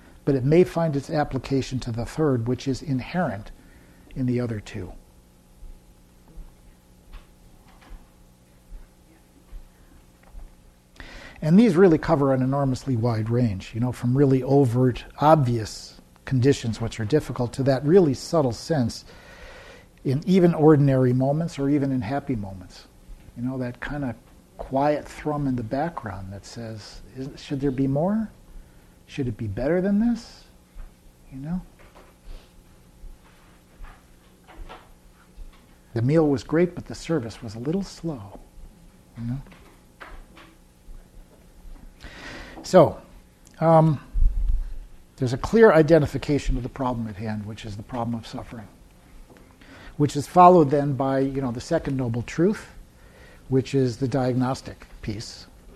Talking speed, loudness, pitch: 125 wpm, -23 LUFS, 120 Hz